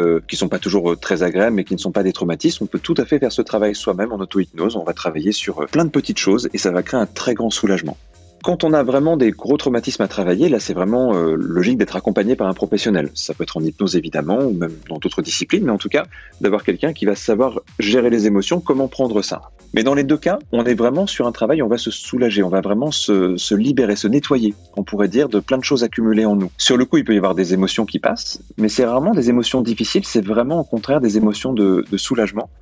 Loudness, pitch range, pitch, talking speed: -18 LUFS, 95-125 Hz, 110 Hz, 265 wpm